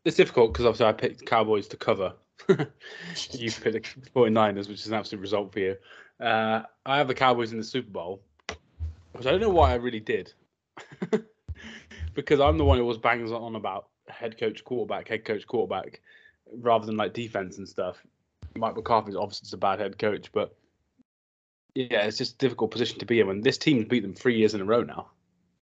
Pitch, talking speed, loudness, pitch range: 110 Hz, 205 wpm, -27 LUFS, 95-130 Hz